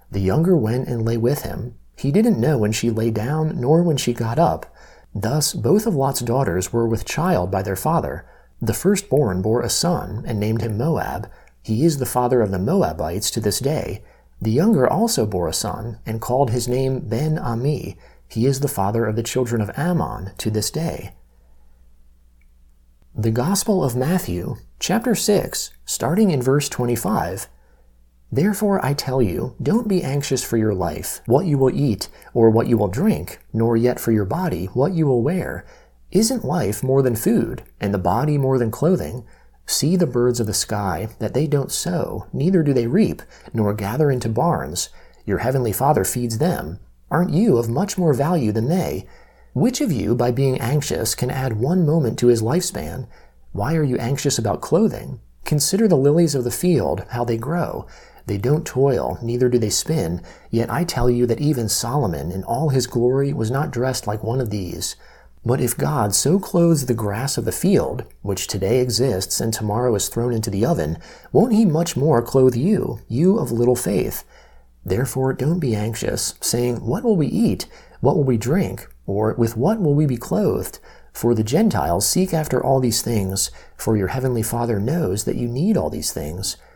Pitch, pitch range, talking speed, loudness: 125 Hz, 110-150 Hz, 190 wpm, -20 LUFS